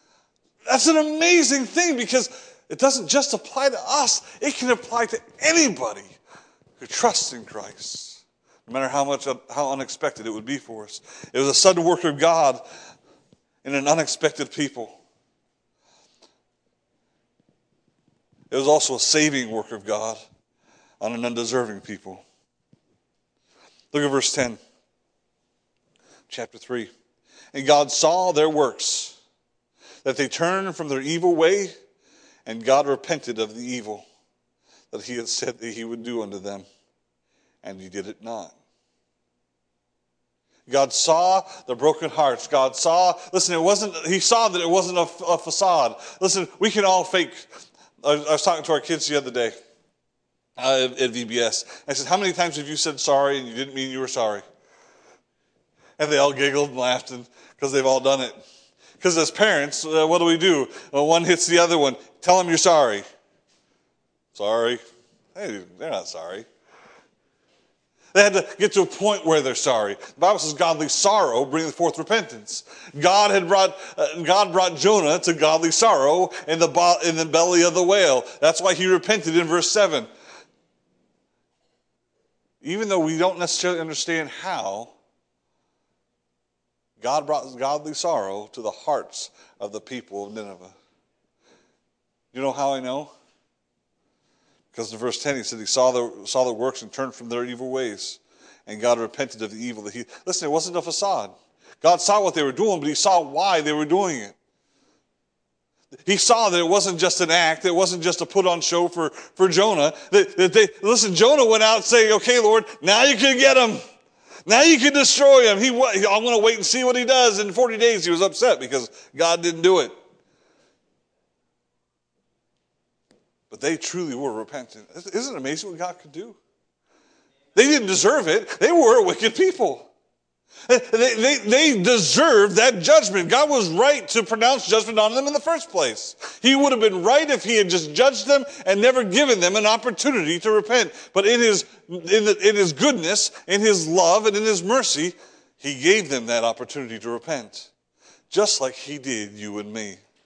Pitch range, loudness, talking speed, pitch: 130-215 Hz, -20 LUFS, 175 wpm, 170 Hz